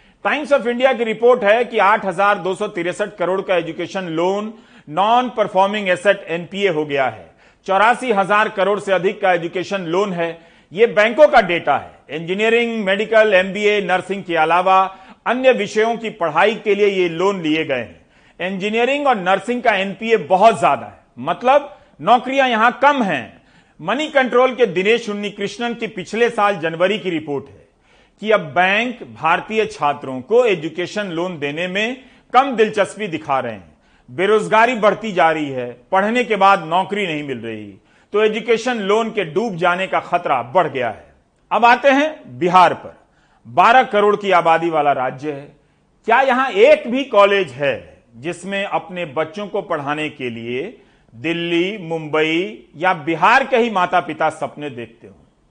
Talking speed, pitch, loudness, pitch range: 160 wpm, 195 Hz, -17 LUFS, 170-220 Hz